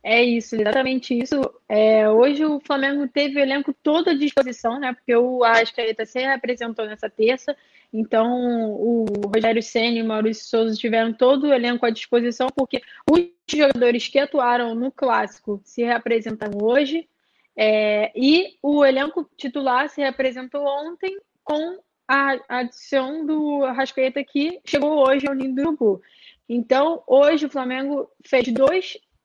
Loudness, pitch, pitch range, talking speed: -21 LUFS, 260 Hz, 230-285 Hz, 150 wpm